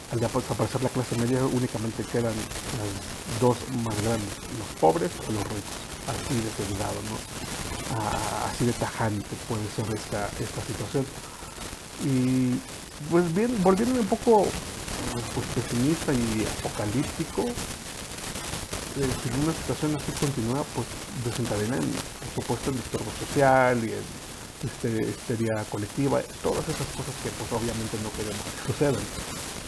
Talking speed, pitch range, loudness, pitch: 135 wpm, 110-135 Hz, -28 LUFS, 120 Hz